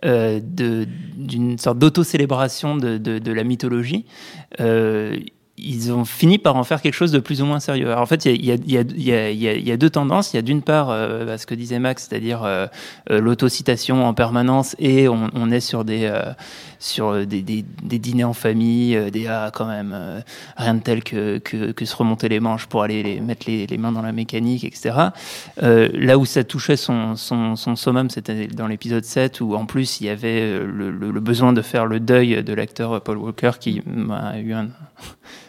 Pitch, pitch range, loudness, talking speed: 120 Hz, 110-130 Hz, -20 LUFS, 220 wpm